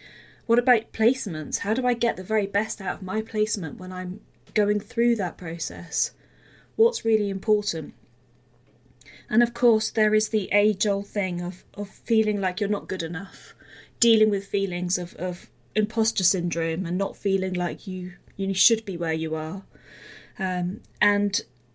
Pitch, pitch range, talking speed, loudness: 200 Hz, 180-215 Hz, 165 wpm, -25 LUFS